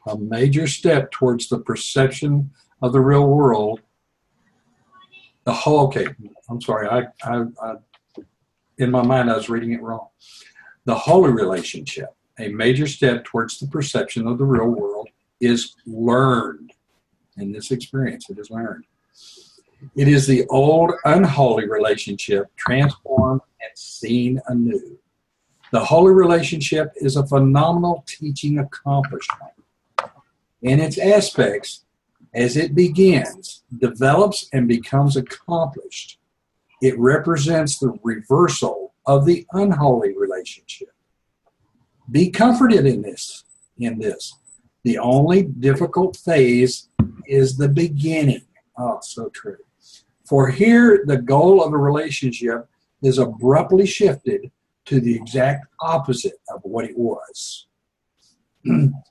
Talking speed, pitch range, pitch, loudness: 120 wpm, 120-160 Hz, 135 Hz, -18 LUFS